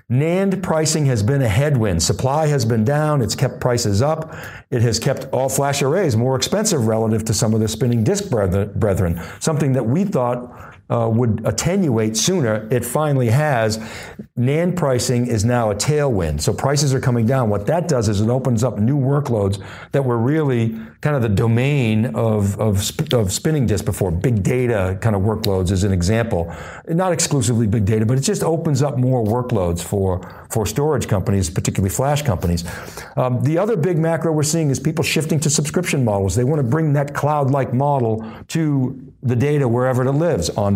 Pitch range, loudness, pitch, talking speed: 110-145 Hz, -18 LUFS, 125 Hz, 190 wpm